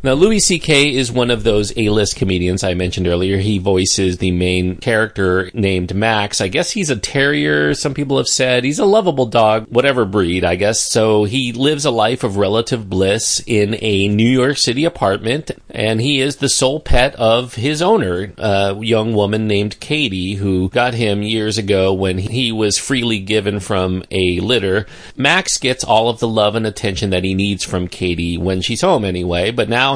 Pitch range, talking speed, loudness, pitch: 95-125 Hz, 195 wpm, -15 LUFS, 105 Hz